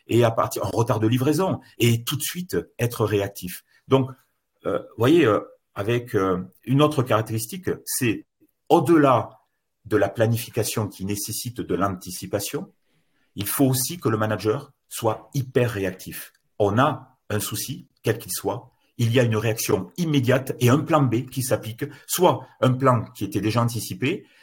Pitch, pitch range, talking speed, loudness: 120 Hz, 105-135 Hz, 165 wpm, -23 LUFS